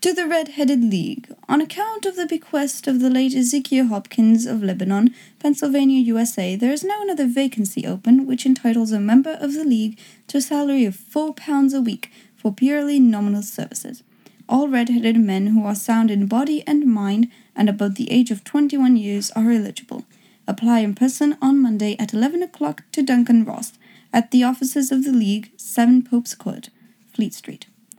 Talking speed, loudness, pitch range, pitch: 180 wpm, -19 LUFS, 220-275 Hz, 245 Hz